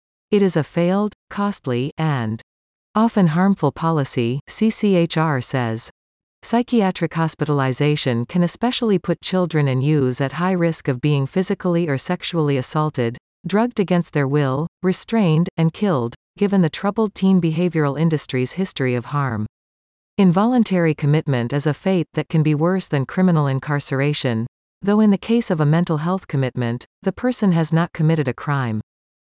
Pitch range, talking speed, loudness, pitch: 135-185 Hz, 150 wpm, -20 LUFS, 160 Hz